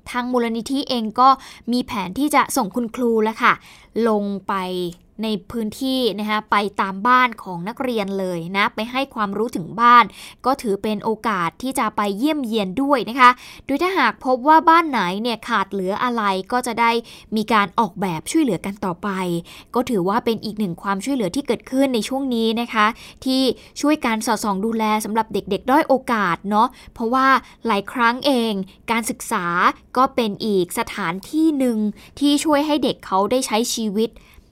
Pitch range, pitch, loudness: 205-255 Hz, 230 Hz, -20 LUFS